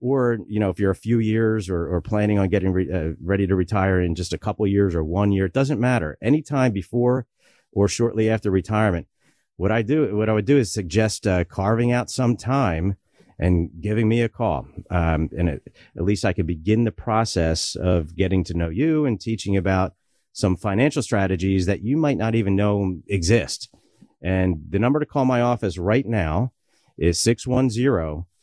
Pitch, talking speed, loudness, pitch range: 105 Hz, 200 wpm, -22 LUFS, 95-115 Hz